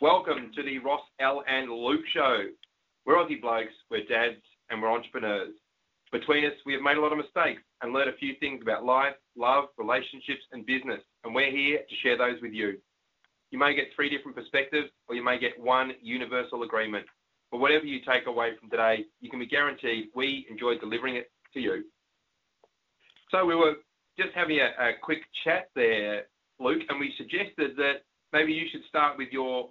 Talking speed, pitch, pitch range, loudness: 190 wpm, 140 Hz, 125-150 Hz, -28 LUFS